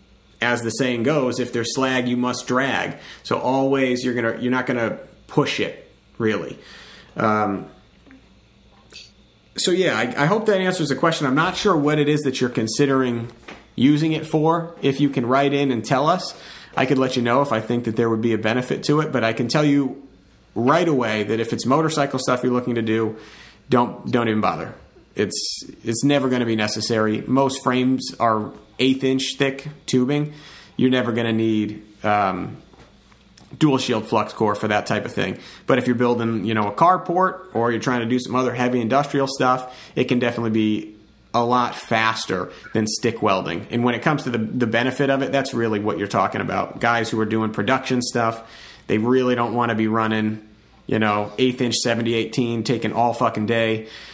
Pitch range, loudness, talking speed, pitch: 110-135 Hz, -21 LUFS, 200 wpm, 120 Hz